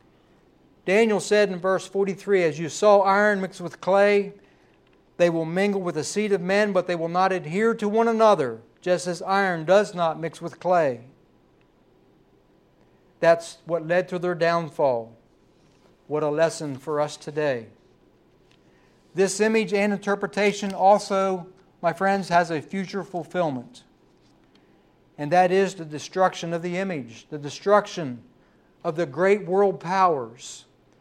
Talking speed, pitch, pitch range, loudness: 145 wpm, 180 Hz, 165-195 Hz, -23 LUFS